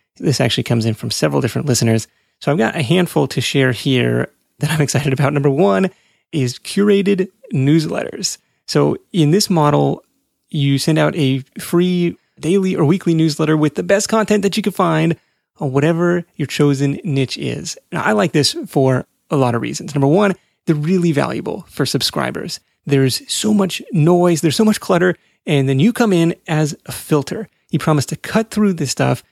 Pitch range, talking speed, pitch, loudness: 140-190 Hz, 185 wpm, 160 Hz, -17 LUFS